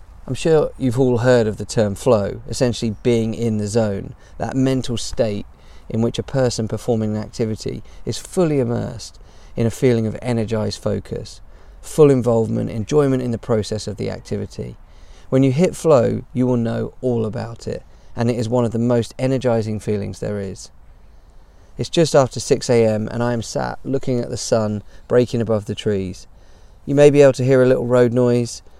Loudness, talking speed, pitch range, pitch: -19 LUFS, 190 wpm, 105-125 Hz, 115 Hz